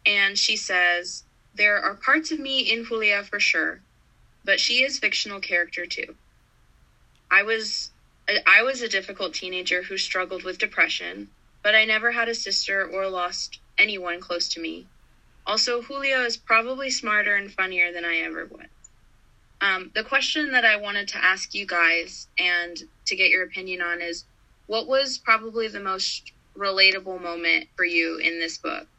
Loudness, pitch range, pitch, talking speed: -22 LUFS, 175-225 Hz, 195 Hz, 170 wpm